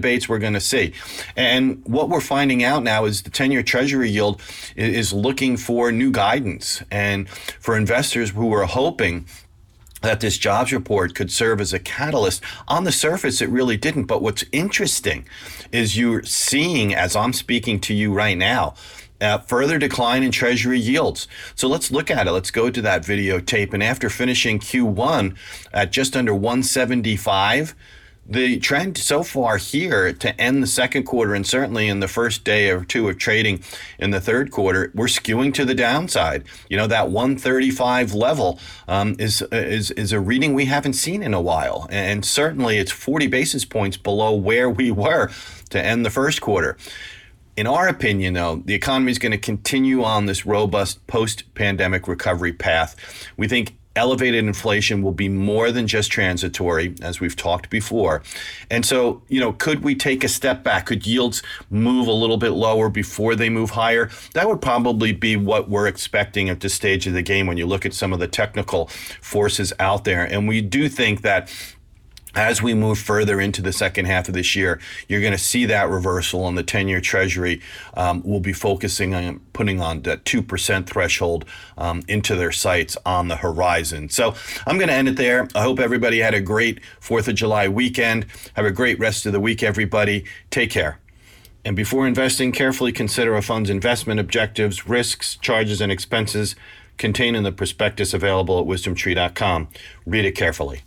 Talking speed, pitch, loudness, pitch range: 185 wpm, 105 Hz, -20 LUFS, 95-120 Hz